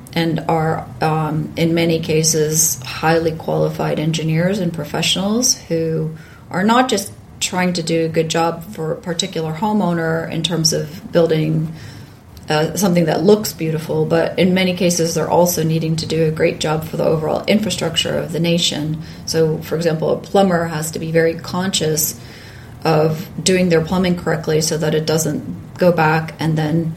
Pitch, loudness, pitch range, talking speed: 160 Hz, -17 LUFS, 155-170 Hz, 170 wpm